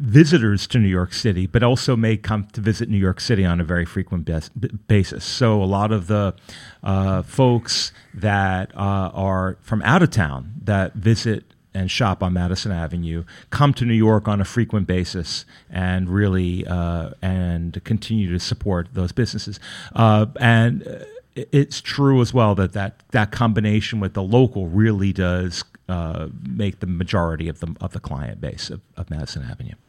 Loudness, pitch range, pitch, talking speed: -20 LUFS, 90-115 Hz, 100 Hz, 175 wpm